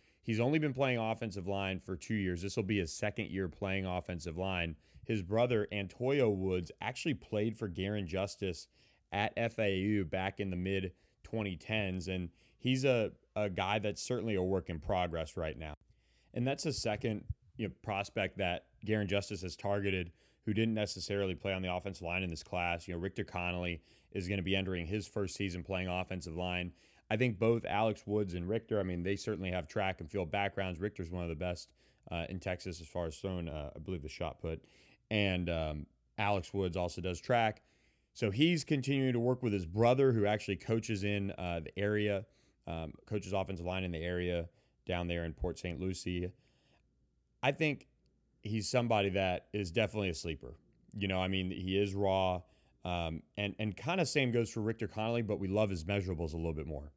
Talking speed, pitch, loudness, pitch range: 200 wpm, 95 Hz, -36 LUFS, 90-105 Hz